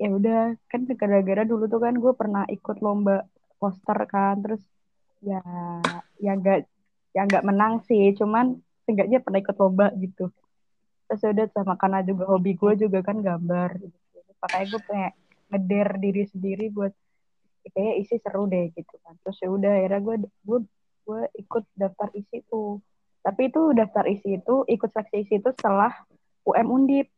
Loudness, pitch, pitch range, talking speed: -24 LUFS, 200 Hz, 195-220 Hz, 160 wpm